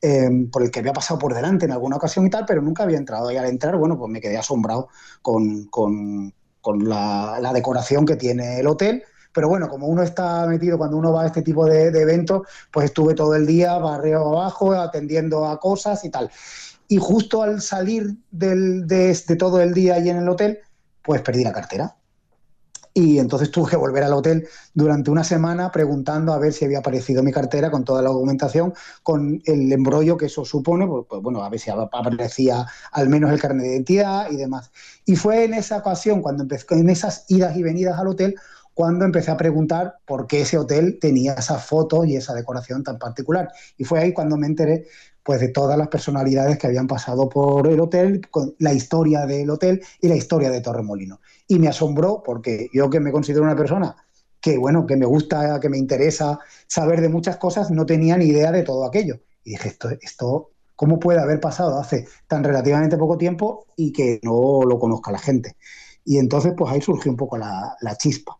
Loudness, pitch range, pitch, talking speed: -20 LUFS, 135-170 Hz, 155 Hz, 210 wpm